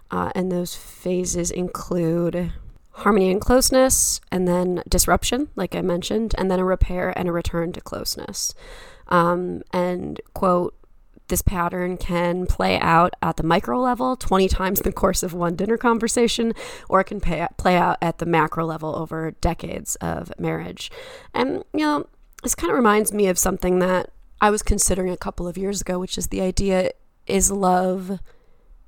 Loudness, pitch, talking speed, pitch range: -22 LUFS, 185 Hz, 170 wpm, 175-210 Hz